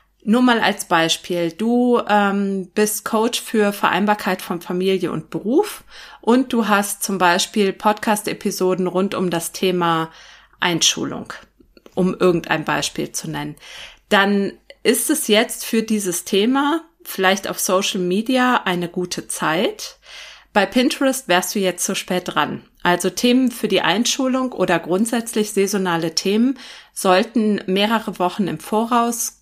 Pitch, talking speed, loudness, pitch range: 200 Hz, 135 wpm, -19 LUFS, 185-230 Hz